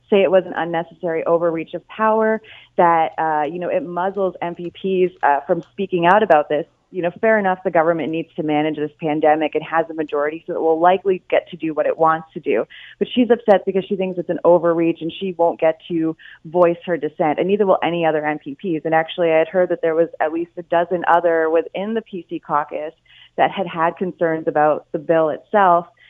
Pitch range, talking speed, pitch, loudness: 160-185 Hz, 220 wpm, 170 Hz, -19 LUFS